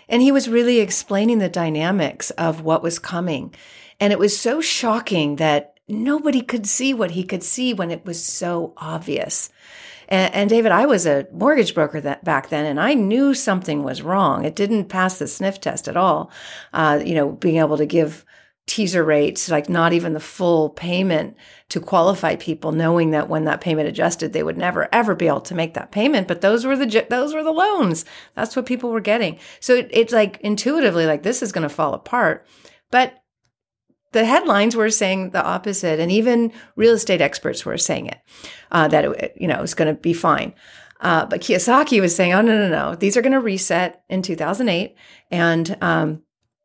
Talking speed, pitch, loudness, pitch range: 200 wpm, 190 Hz, -19 LUFS, 160-230 Hz